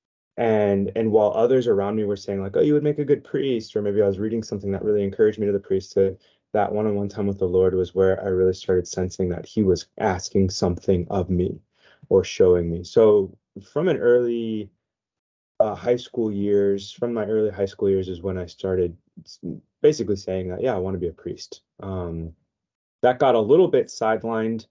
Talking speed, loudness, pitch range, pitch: 210 wpm, -22 LUFS, 95-110 Hz, 100 Hz